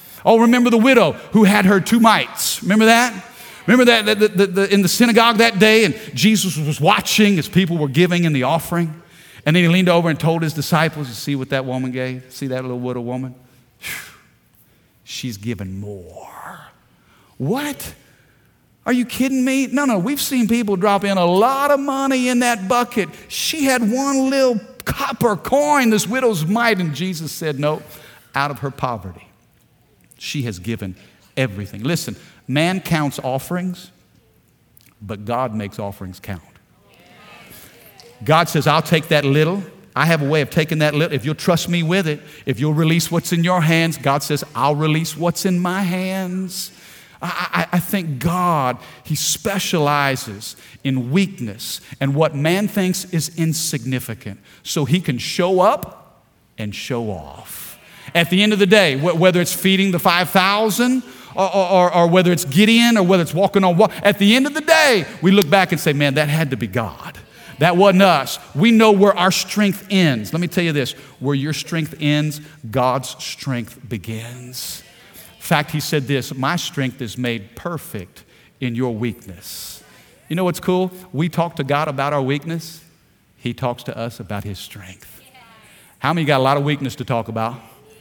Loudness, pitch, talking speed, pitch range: -17 LUFS, 160 Hz, 180 wpm, 130-195 Hz